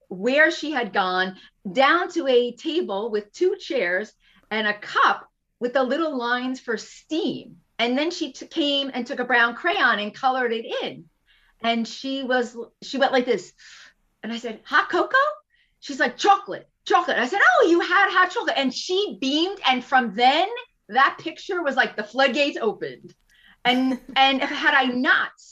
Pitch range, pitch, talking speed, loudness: 245-330 Hz, 270 Hz, 180 wpm, -22 LUFS